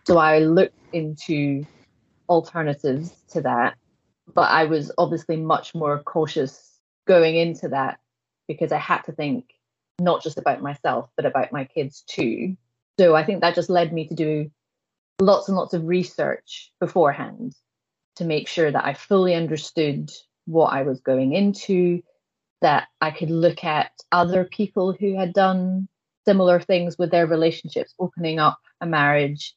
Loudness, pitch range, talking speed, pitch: -22 LUFS, 155-180 Hz, 155 wpm, 165 Hz